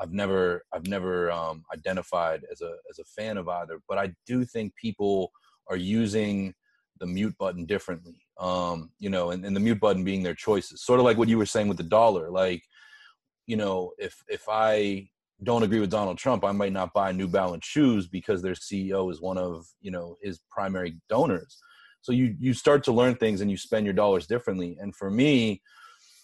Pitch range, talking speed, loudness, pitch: 90-110 Hz, 205 wpm, -27 LUFS, 100 Hz